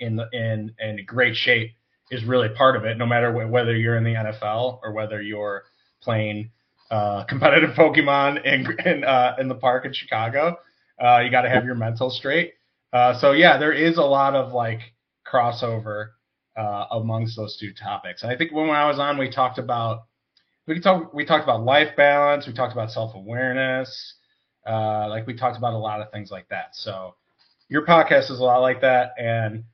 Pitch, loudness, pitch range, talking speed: 120 Hz, -21 LUFS, 110-130 Hz, 200 wpm